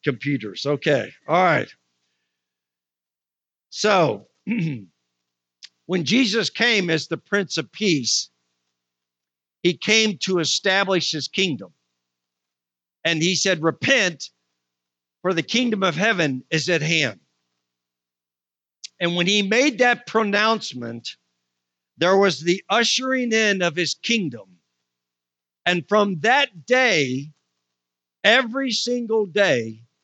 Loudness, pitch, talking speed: -20 LUFS, 145 Hz, 105 wpm